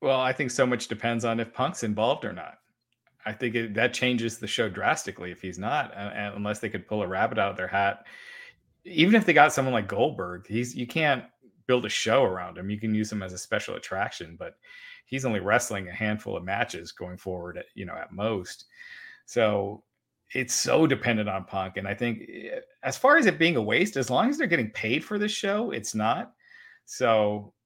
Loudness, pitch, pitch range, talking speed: -26 LUFS, 115 Hz, 105-165 Hz, 215 wpm